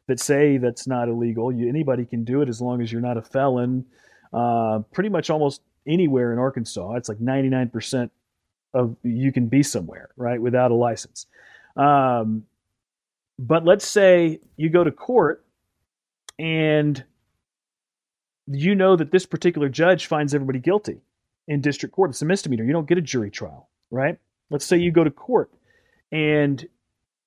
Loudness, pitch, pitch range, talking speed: -21 LUFS, 135 Hz, 120-155 Hz, 165 wpm